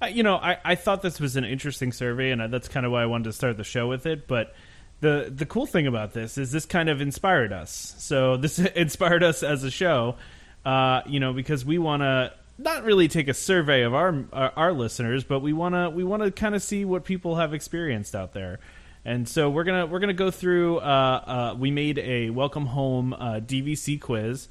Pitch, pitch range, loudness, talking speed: 145 Hz, 125-175 Hz, -25 LUFS, 235 wpm